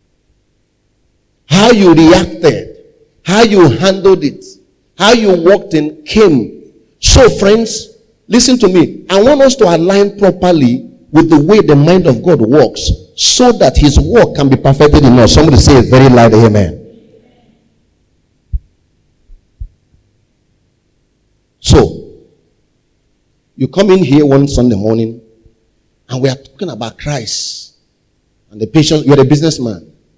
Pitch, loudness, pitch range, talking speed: 150 Hz, -8 LUFS, 115-195 Hz, 130 wpm